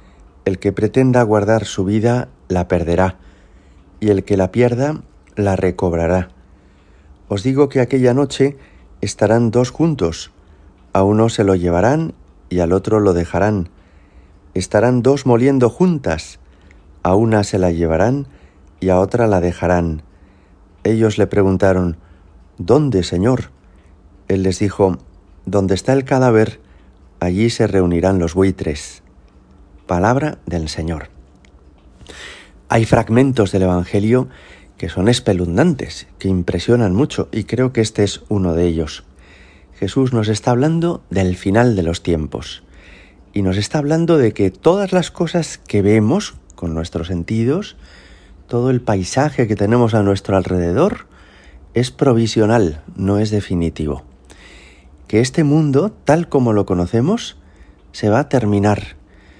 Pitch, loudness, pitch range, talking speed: 95 Hz, -16 LUFS, 85-115 Hz, 135 wpm